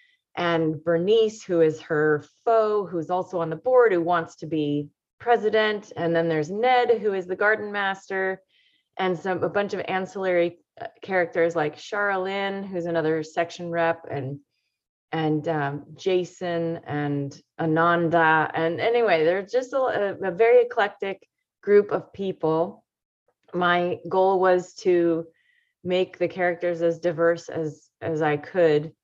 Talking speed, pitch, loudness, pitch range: 140 wpm, 175 Hz, -24 LUFS, 165-195 Hz